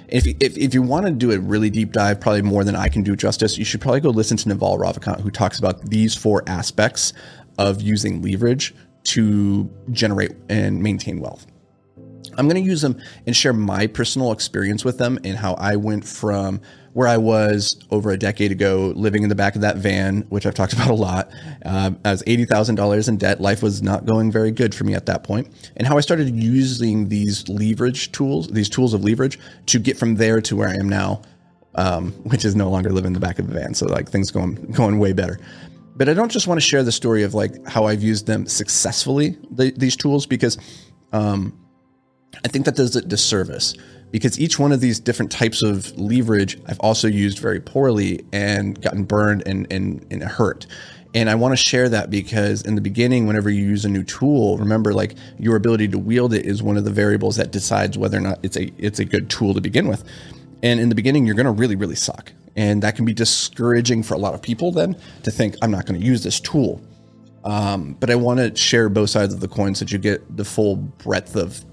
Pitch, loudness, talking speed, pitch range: 105 Hz, -19 LUFS, 230 wpm, 100-120 Hz